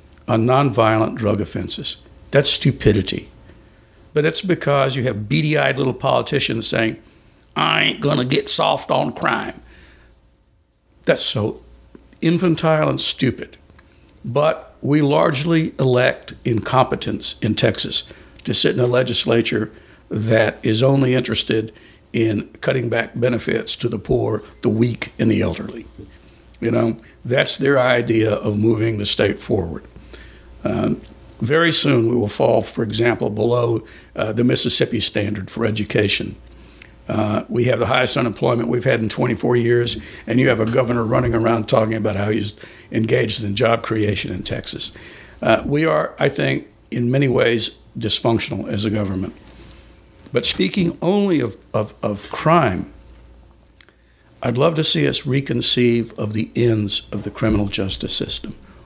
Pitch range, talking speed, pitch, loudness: 105-130 Hz, 145 wpm, 115 Hz, -18 LUFS